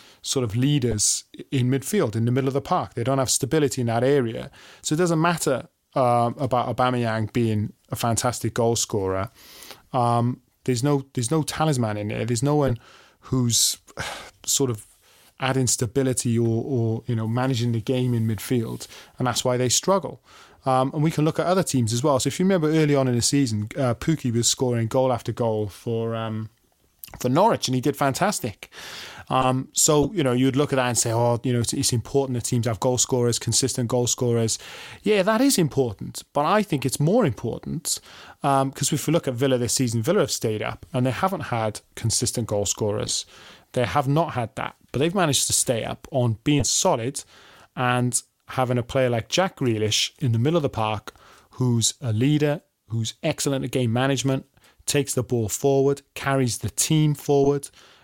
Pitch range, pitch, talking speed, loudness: 115-140 Hz, 125 Hz, 205 wpm, -23 LUFS